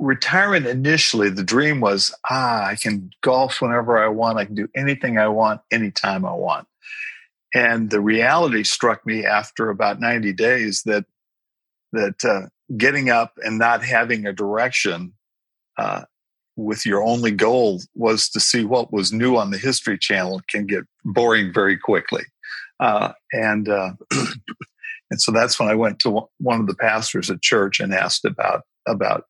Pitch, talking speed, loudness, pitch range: 115 Hz, 165 wpm, -19 LUFS, 105-125 Hz